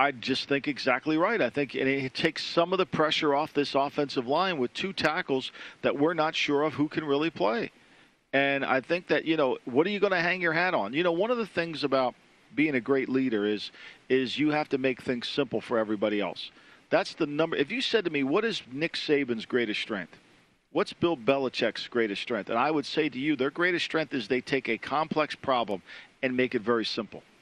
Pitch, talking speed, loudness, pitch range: 145 Hz, 230 wpm, -28 LUFS, 130-165 Hz